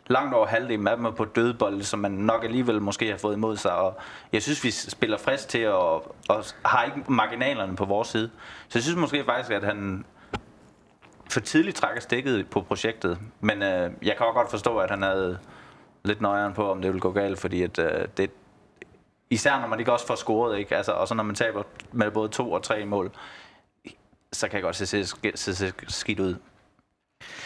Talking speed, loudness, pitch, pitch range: 210 wpm, -26 LUFS, 105 Hz, 100-115 Hz